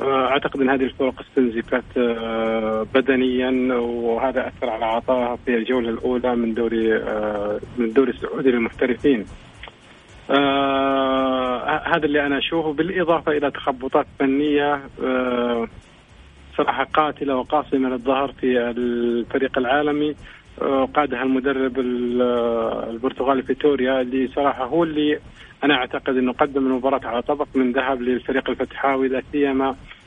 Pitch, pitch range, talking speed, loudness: 130 Hz, 120-140 Hz, 120 wpm, -21 LUFS